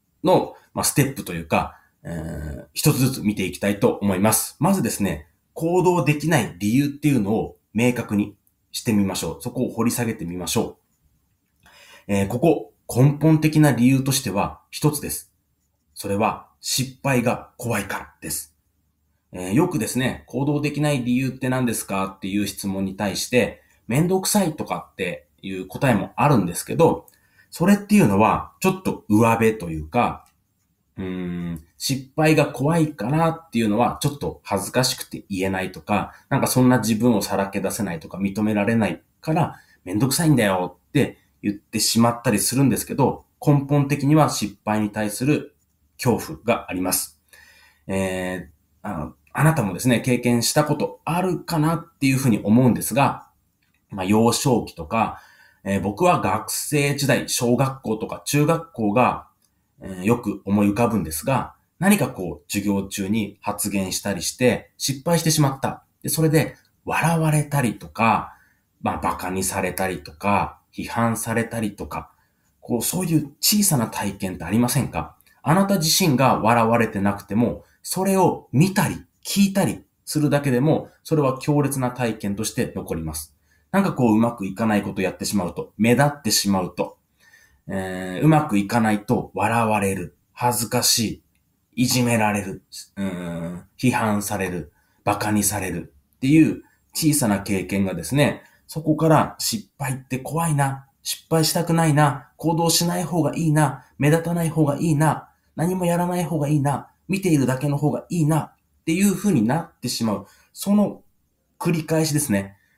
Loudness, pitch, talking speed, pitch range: -22 LUFS, 120 Hz, 330 characters per minute, 100-150 Hz